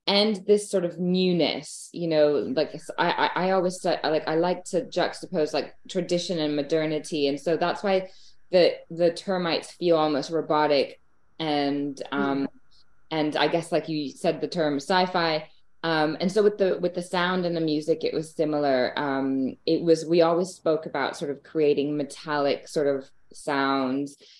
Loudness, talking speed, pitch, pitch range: -25 LUFS, 175 wpm, 160 Hz, 145-175 Hz